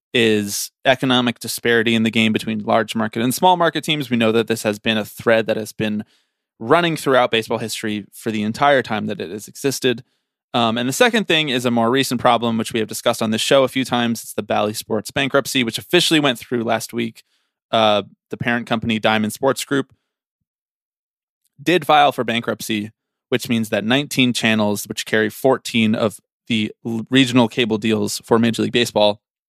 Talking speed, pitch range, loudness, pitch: 195 wpm, 110-130 Hz, -18 LUFS, 115 Hz